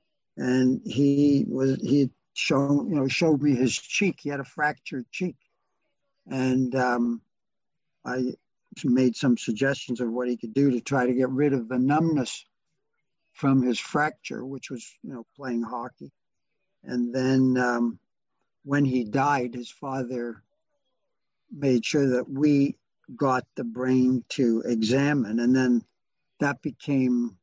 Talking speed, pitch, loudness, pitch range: 140 wpm, 130 Hz, -25 LUFS, 125-145 Hz